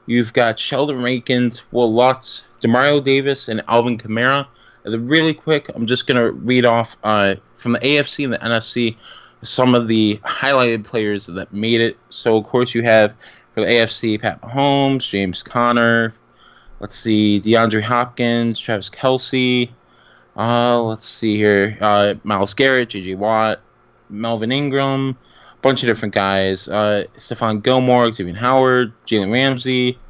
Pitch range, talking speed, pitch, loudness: 110-125 Hz, 150 wpm, 115 Hz, -17 LUFS